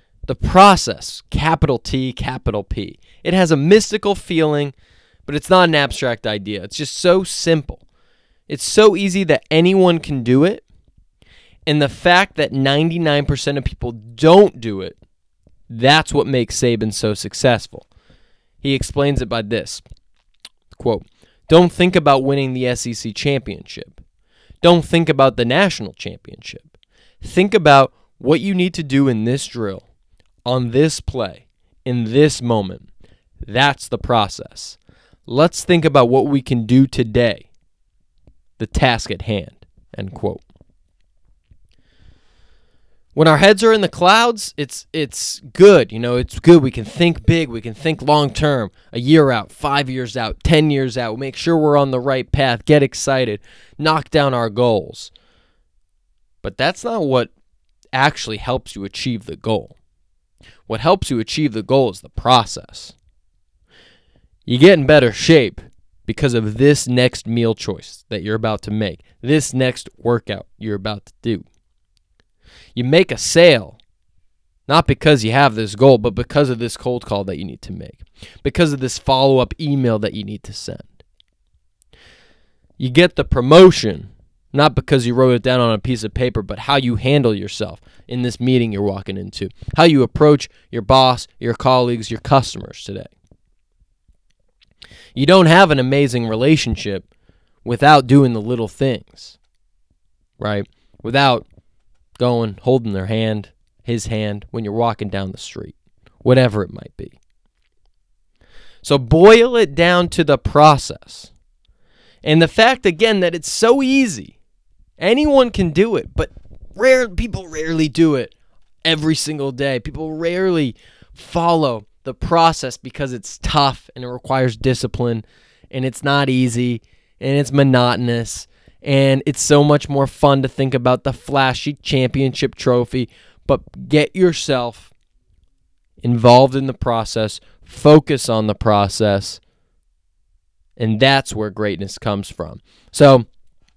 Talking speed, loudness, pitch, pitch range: 150 wpm, -16 LUFS, 125 Hz, 105-145 Hz